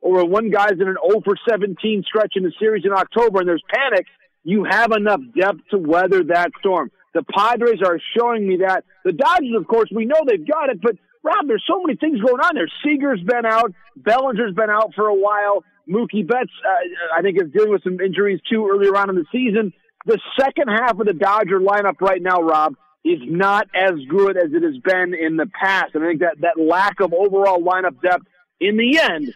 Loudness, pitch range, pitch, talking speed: -18 LUFS, 185-235 Hz, 205 Hz, 220 wpm